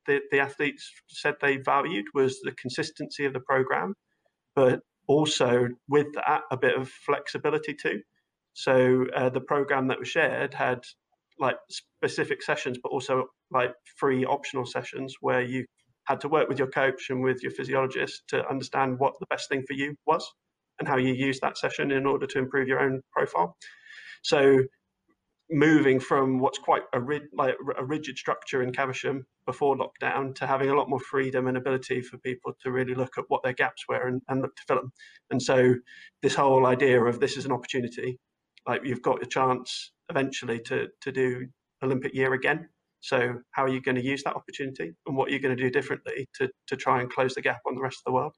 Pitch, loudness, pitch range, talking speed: 135 Hz, -27 LUFS, 130-145 Hz, 200 wpm